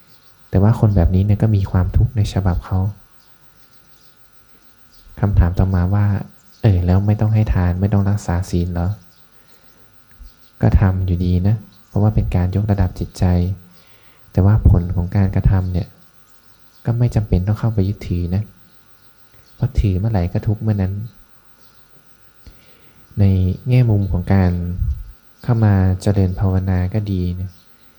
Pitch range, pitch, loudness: 90-105 Hz, 95 Hz, -18 LUFS